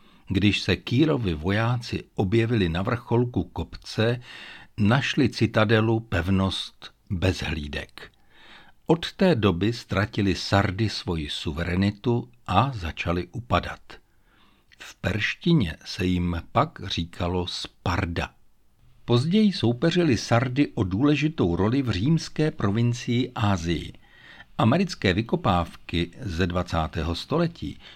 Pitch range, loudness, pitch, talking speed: 90-120 Hz, -25 LUFS, 105 Hz, 95 wpm